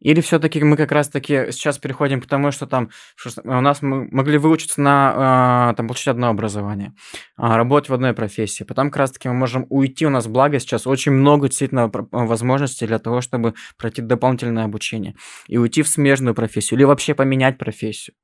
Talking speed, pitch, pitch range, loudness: 180 wpm, 130 Hz, 115-140 Hz, -18 LUFS